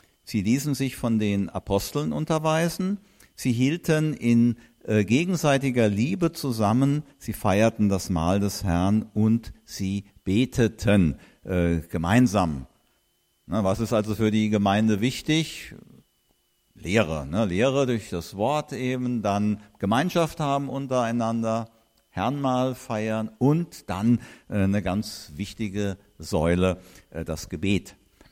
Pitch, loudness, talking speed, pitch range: 110 Hz, -25 LUFS, 120 wpm, 100-130 Hz